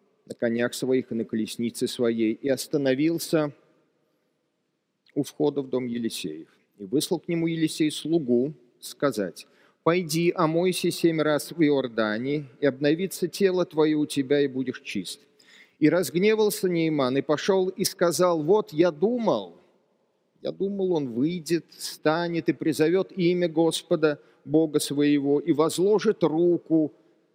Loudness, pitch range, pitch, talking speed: -25 LUFS, 140-175 Hz, 155 Hz, 130 wpm